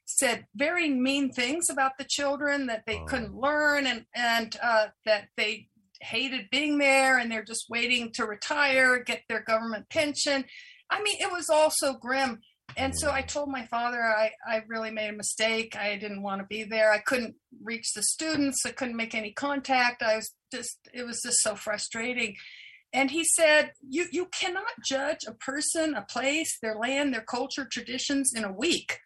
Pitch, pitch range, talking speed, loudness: 250 Hz, 225-285 Hz, 190 wpm, -27 LUFS